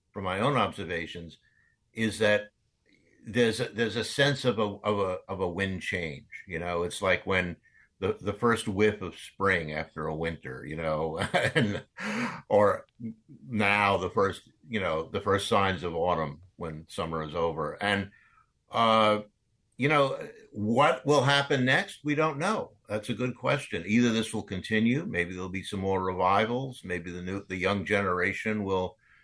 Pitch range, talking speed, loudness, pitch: 90-115 Hz, 170 wpm, -28 LUFS, 100 Hz